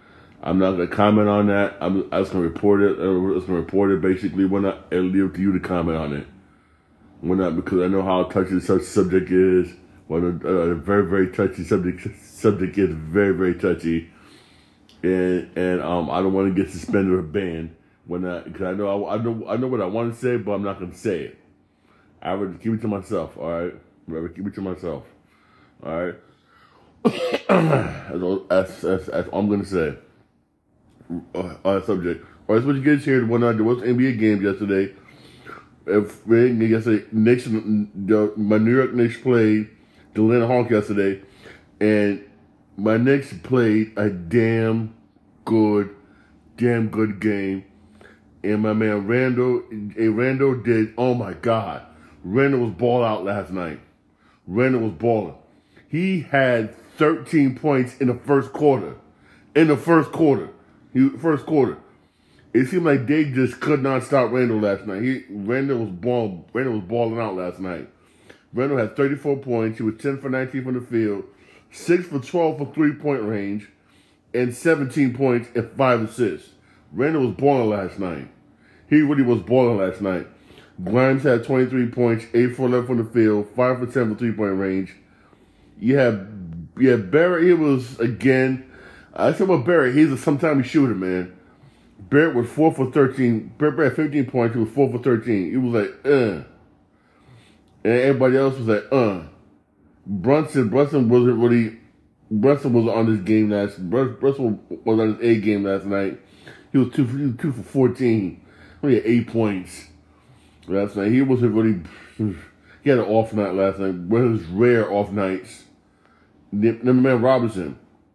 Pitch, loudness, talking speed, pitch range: 110 Hz, -21 LUFS, 180 wpm, 95-125 Hz